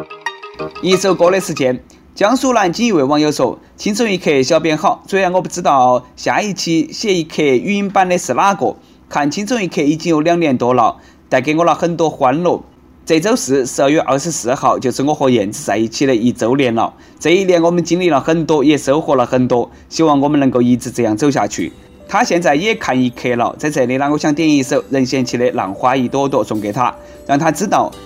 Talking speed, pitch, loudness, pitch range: 315 characters per minute, 155 Hz, -14 LUFS, 130-180 Hz